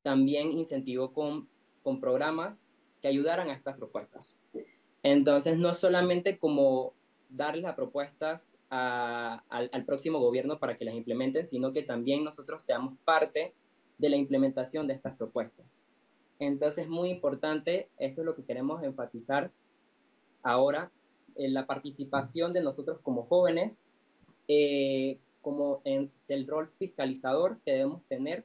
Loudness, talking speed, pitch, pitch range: -31 LUFS, 135 wpm, 145 Hz, 135-165 Hz